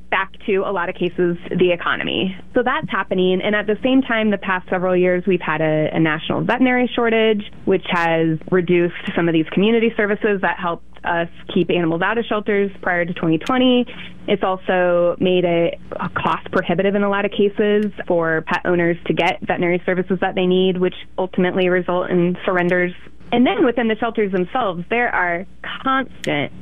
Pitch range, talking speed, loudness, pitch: 175-210 Hz, 185 wpm, -19 LUFS, 185 Hz